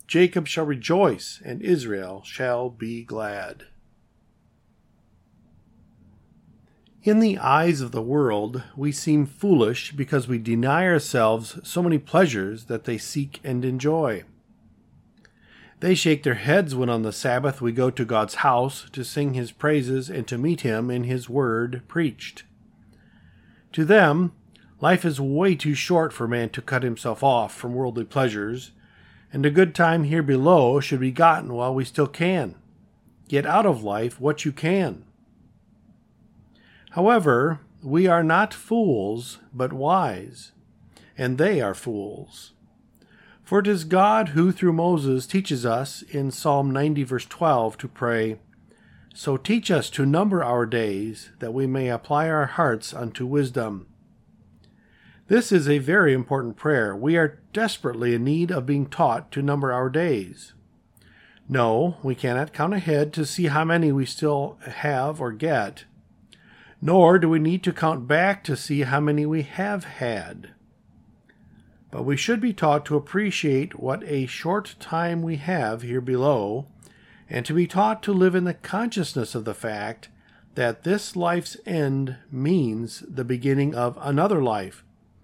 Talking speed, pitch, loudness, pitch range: 150 wpm, 145 Hz, -23 LUFS, 125-170 Hz